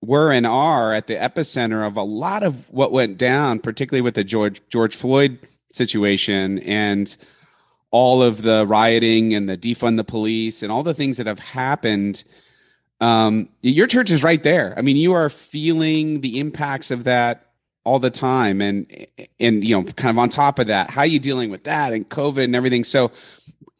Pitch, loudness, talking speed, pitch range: 120 Hz, -18 LUFS, 190 wpm, 110-140 Hz